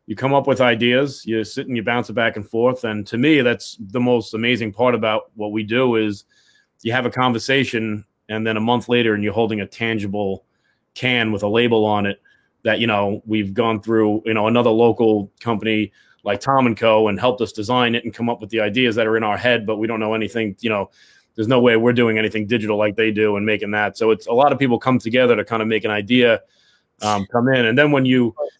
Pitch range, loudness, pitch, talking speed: 110-120 Hz, -18 LUFS, 115 Hz, 250 wpm